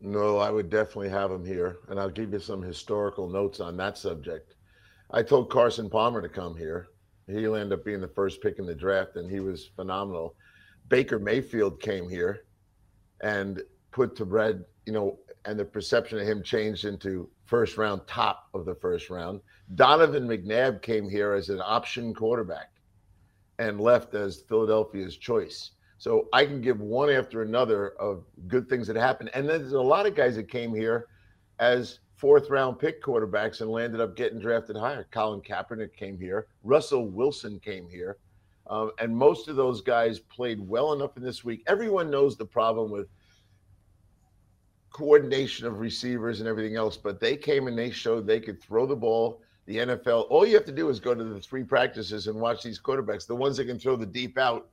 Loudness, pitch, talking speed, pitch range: -27 LUFS, 110 Hz, 190 wpm, 100-120 Hz